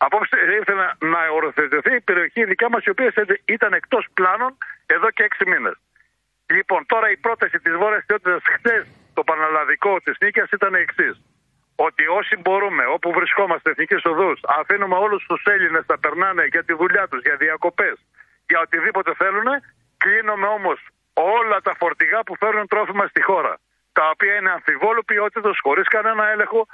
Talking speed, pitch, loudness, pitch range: 160 wpm, 200 Hz, -18 LUFS, 165-215 Hz